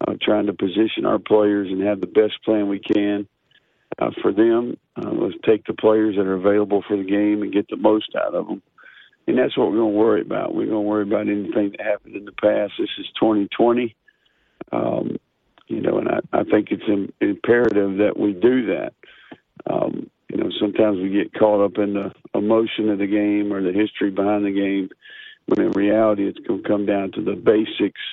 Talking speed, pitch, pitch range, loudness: 215 wpm, 105 Hz, 100-115 Hz, -20 LUFS